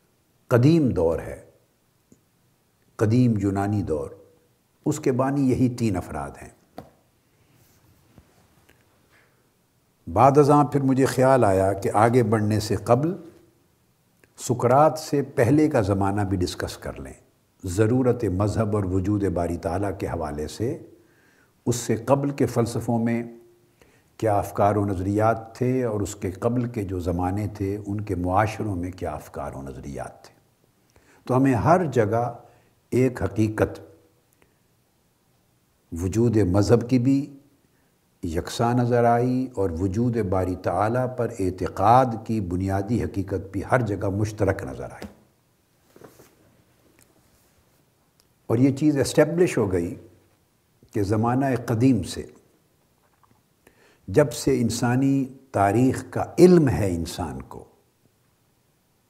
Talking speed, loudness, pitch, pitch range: 120 wpm, -23 LUFS, 115 Hz, 95-125 Hz